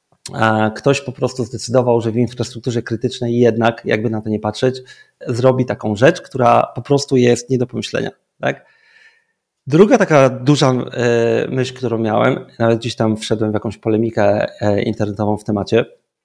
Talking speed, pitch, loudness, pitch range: 150 wpm, 120 Hz, -16 LUFS, 110-130 Hz